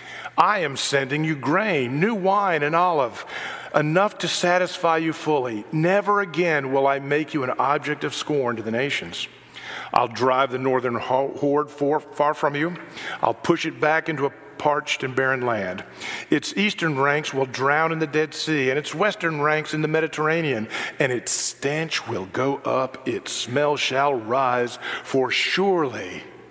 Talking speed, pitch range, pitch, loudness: 170 wpm, 140-165 Hz, 150 Hz, -22 LUFS